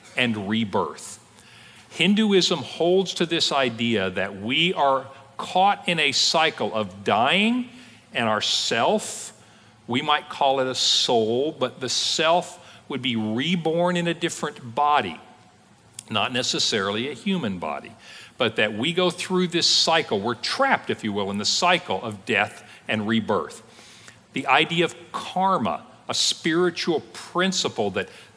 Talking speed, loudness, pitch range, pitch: 140 wpm, -22 LUFS, 120-180 Hz, 160 Hz